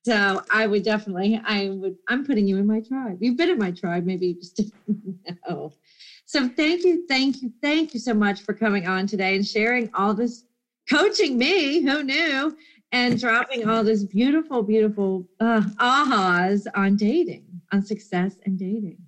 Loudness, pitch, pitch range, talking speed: -22 LUFS, 220 Hz, 195-250 Hz, 180 wpm